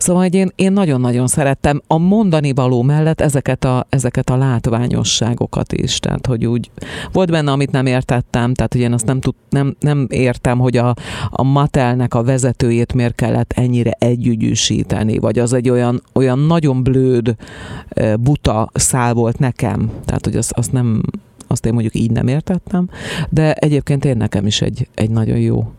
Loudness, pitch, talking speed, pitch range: -15 LUFS, 125 Hz, 170 wpm, 120-140 Hz